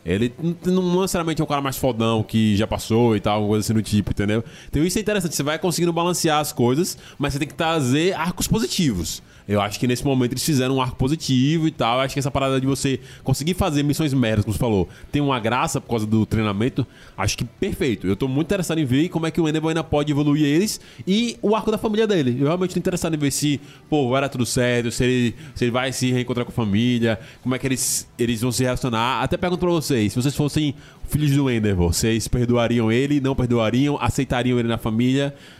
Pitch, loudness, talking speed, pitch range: 135 Hz, -21 LUFS, 240 wpm, 120-155 Hz